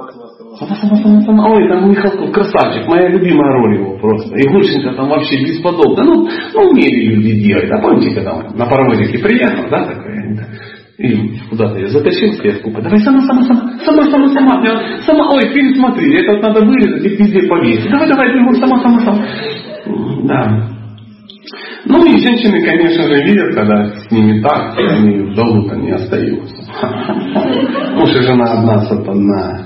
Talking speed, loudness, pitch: 155 wpm, -11 LUFS, 175 Hz